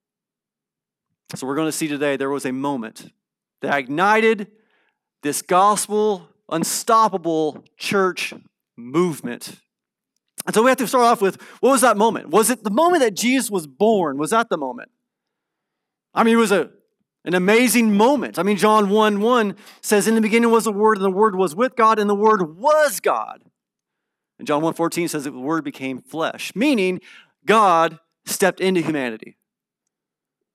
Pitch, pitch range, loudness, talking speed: 205 Hz, 165-225 Hz, -19 LUFS, 170 wpm